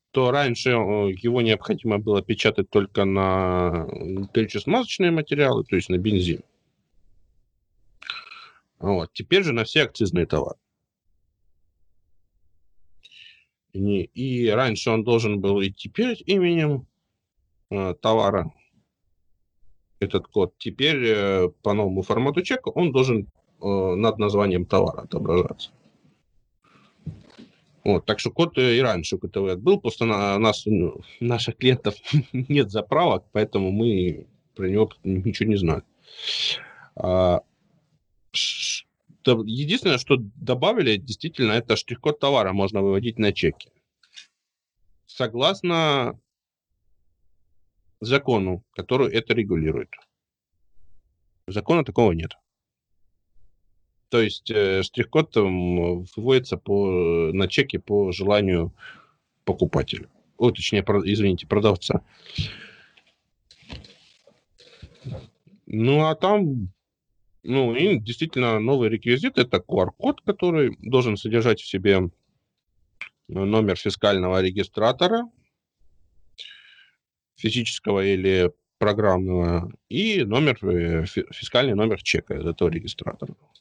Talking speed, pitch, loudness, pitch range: 95 wpm, 105 Hz, -23 LUFS, 95-125 Hz